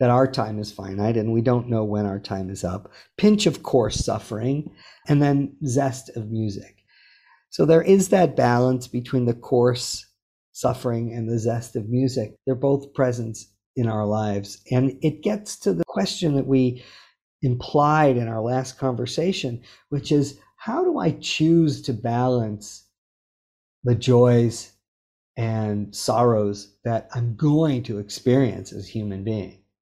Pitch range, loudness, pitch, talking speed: 105-140 Hz, -22 LUFS, 120 Hz, 155 wpm